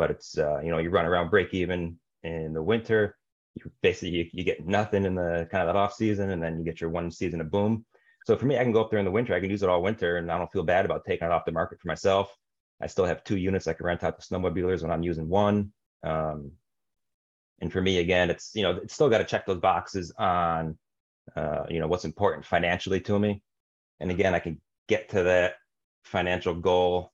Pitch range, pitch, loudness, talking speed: 85-100 Hz, 90 Hz, -27 LUFS, 250 wpm